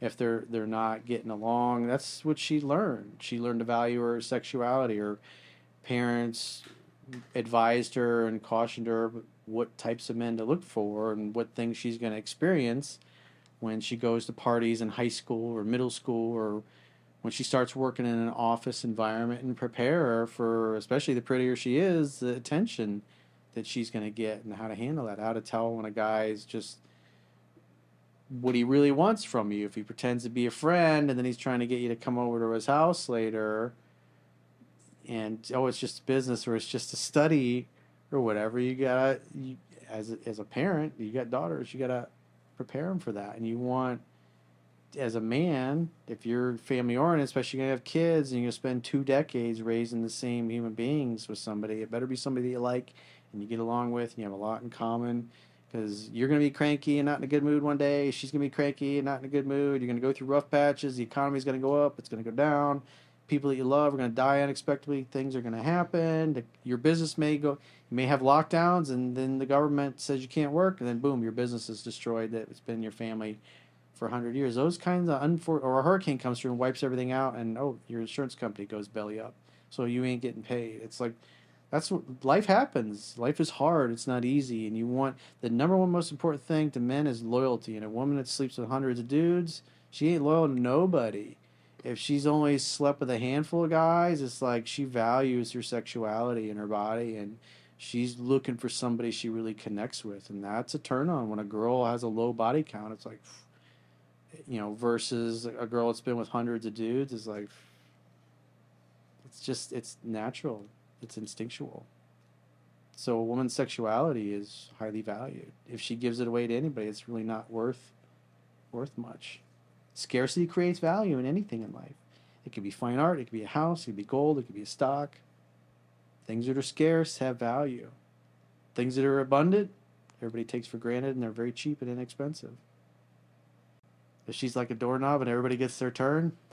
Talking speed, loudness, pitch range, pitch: 210 wpm, -31 LUFS, 110-135 Hz, 120 Hz